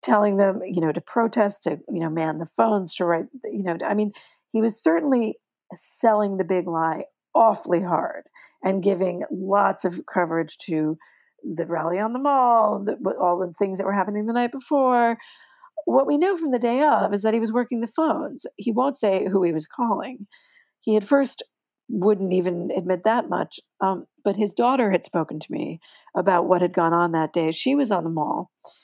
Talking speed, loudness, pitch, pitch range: 200 wpm, -23 LUFS, 205 Hz, 180-245 Hz